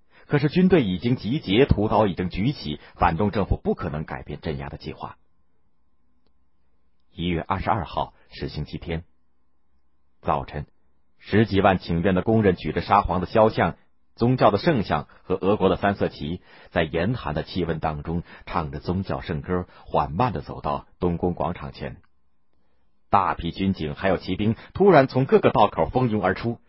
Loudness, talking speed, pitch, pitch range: -23 LUFS, 245 characters per minute, 85 Hz, 75-100 Hz